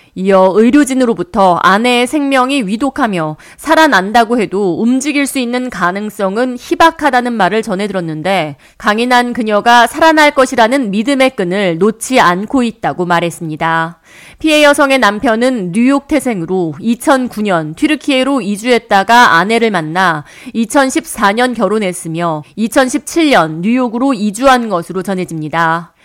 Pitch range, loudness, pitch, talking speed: 185-260 Hz, -11 LUFS, 230 Hz, 300 characters per minute